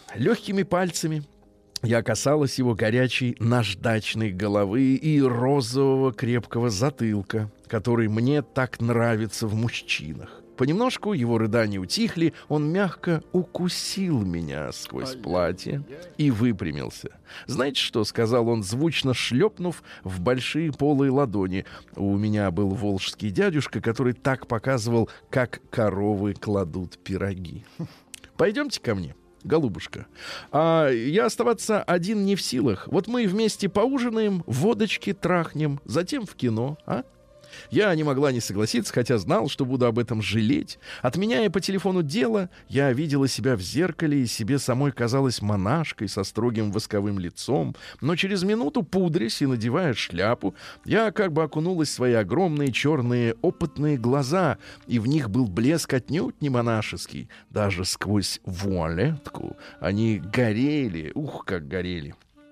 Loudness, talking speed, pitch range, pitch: -25 LUFS, 130 wpm, 110-160 Hz, 130 Hz